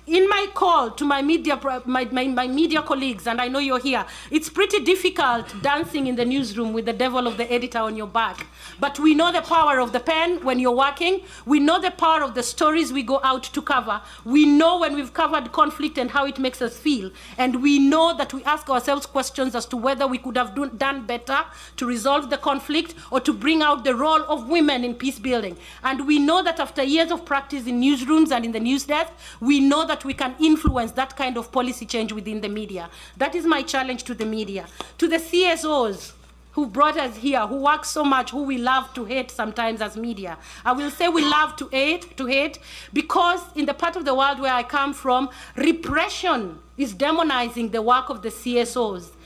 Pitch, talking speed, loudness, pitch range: 275 Hz, 220 wpm, -22 LUFS, 250-305 Hz